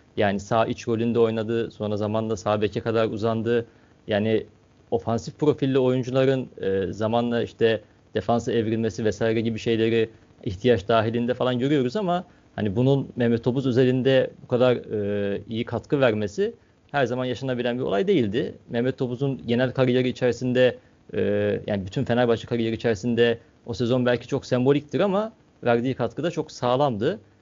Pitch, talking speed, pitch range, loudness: 120 Hz, 140 wpm, 115-130 Hz, -24 LUFS